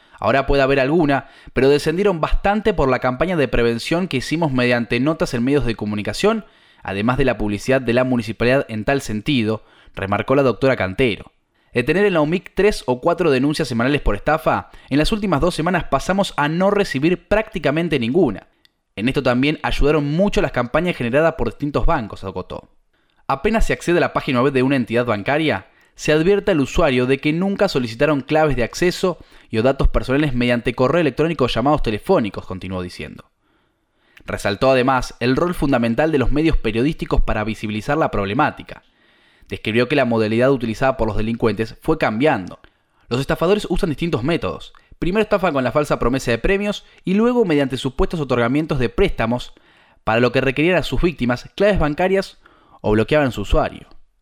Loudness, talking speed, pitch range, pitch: -19 LUFS, 175 wpm, 120-165 Hz, 140 Hz